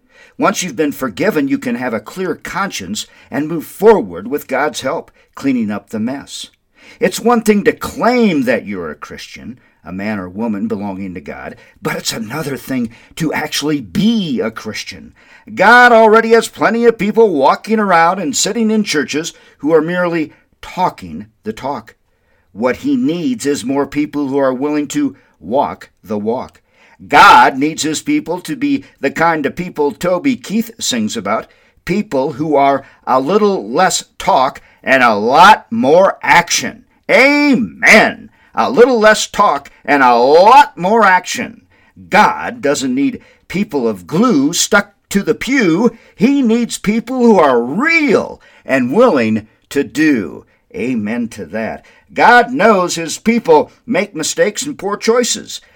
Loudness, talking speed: -13 LUFS, 155 wpm